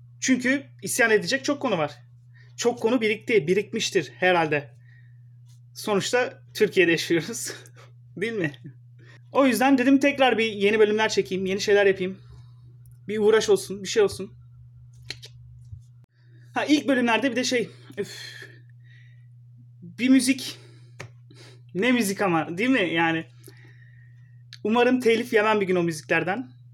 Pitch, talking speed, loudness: 165 Hz, 125 wpm, -23 LUFS